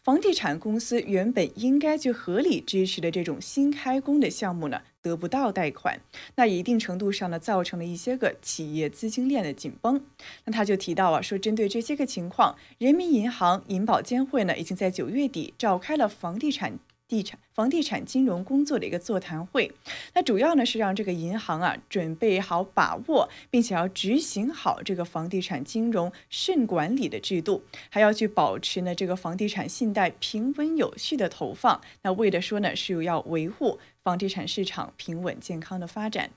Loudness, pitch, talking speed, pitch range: -27 LUFS, 205 Hz, 290 characters per minute, 180-250 Hz